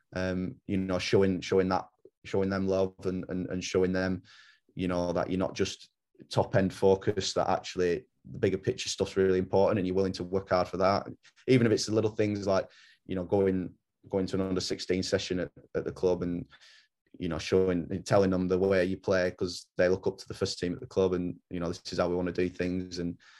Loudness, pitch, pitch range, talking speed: -30 LUFS, 95 Hz, 90-95 Hz, 240 wpm